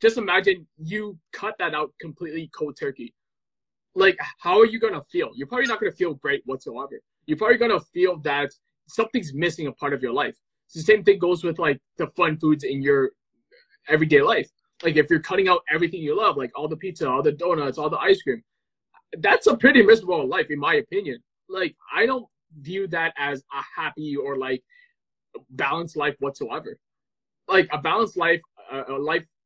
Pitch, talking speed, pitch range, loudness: 170 Hz, 195 wpm, 150-225 Hz, -22 LUFS